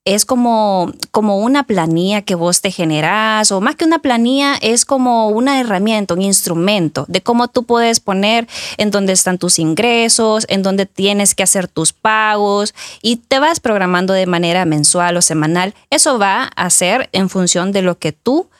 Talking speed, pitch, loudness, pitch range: 180 wpm, 200 Hz, -13 LUFS, 180-230 Hz